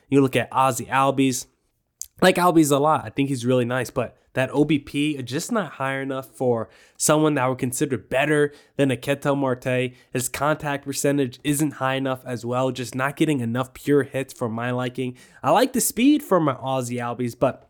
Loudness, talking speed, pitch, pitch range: -22 LUFS, 200 wpm, 135 Hz, 125-145 Hz